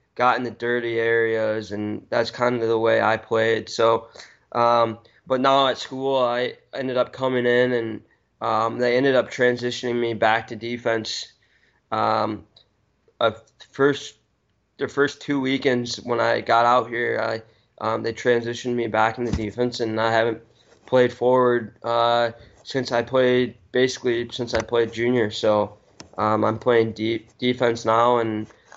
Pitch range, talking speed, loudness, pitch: 115-125 Hz, 165 wpm, -22 LUFS, 120 Hz